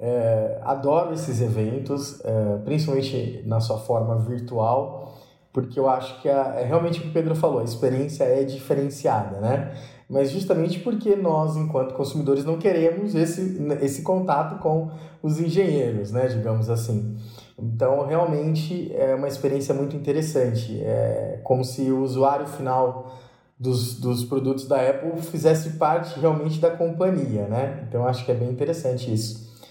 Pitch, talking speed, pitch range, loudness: 135 Hz, 145 wpm, 125-160 Hz, -24 LUFS